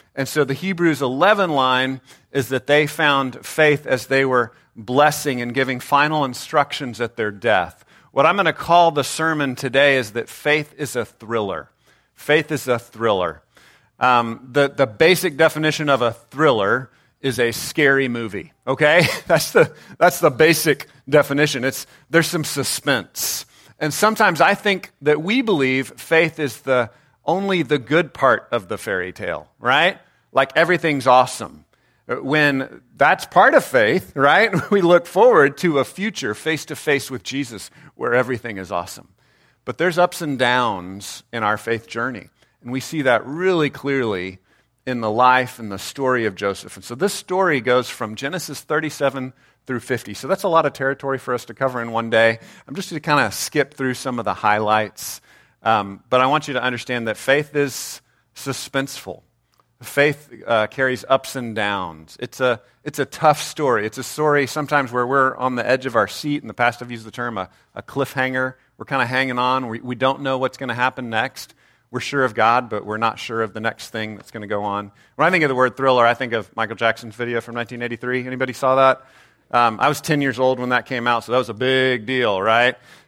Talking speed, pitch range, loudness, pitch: 200 wpm, 120-145 Hz, -19 LUFS, 130 Hz